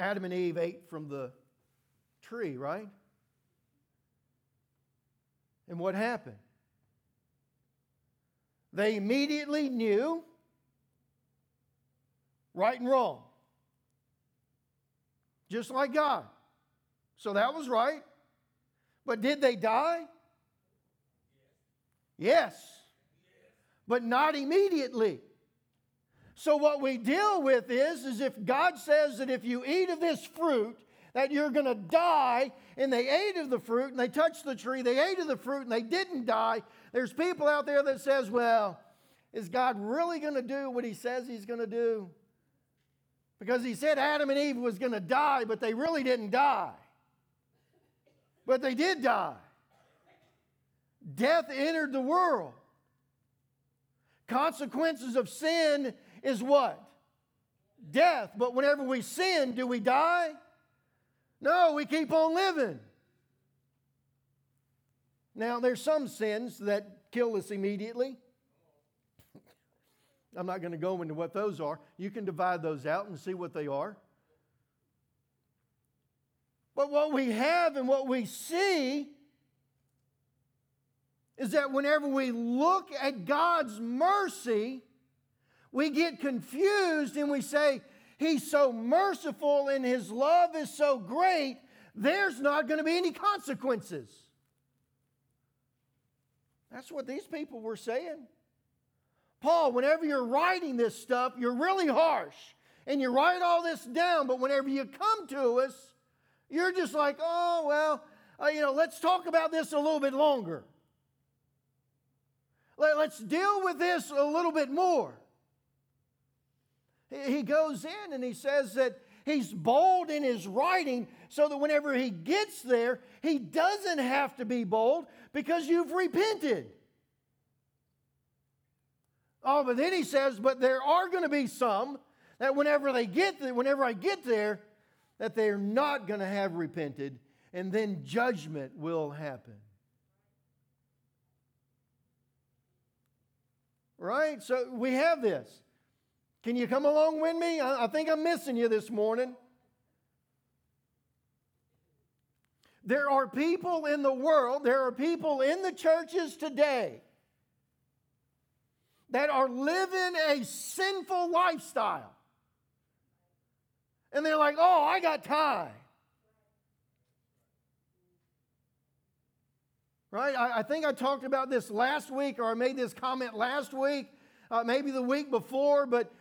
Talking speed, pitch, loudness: 130 wpm, 255 Hz, -30 LUFS